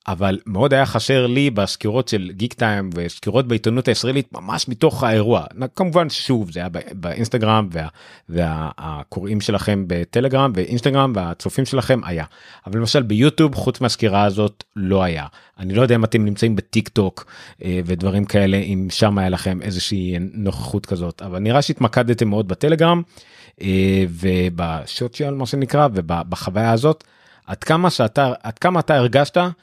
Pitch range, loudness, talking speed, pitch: 95-130 Hz, -19 LUFS, 140 wpm, 110 Hz